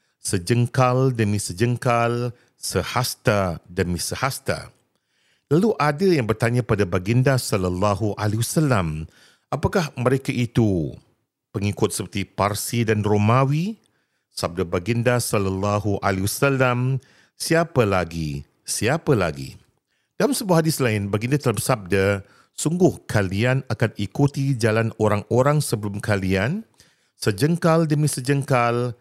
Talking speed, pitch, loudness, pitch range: 105 wpm, 120 Hz, -22 LUFS, 100-135 Hz